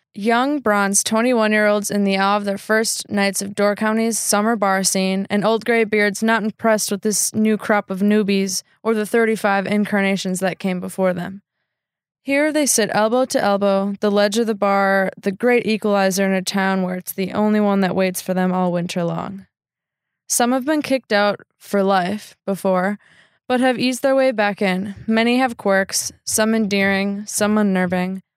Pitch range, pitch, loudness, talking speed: 195-220 Hz, 205 Hz, -18 LUFS, 190 wpm